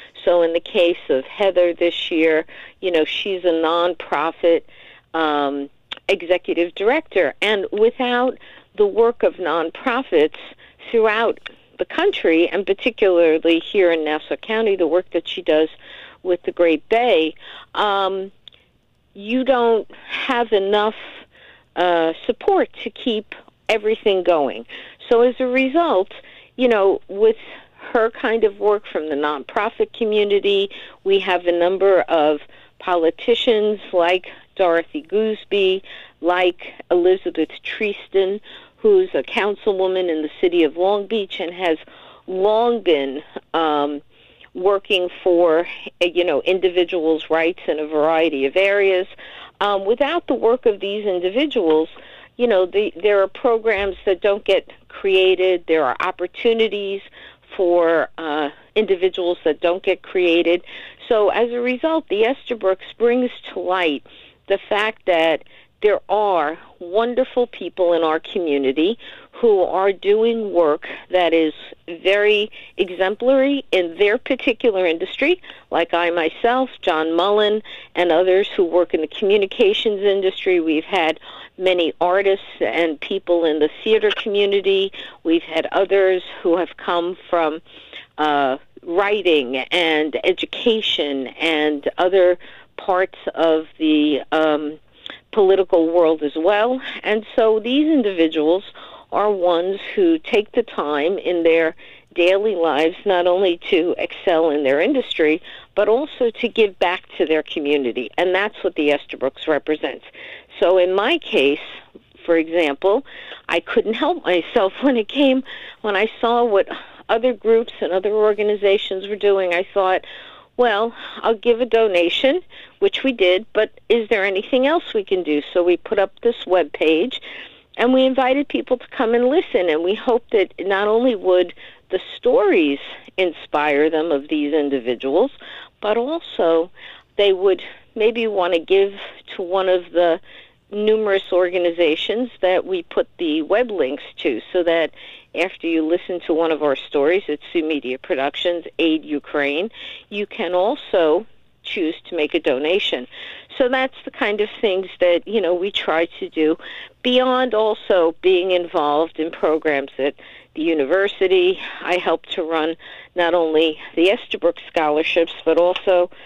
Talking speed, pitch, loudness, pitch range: 140 wpm, 190 Hz, -19 LUFS, 165-230 Hz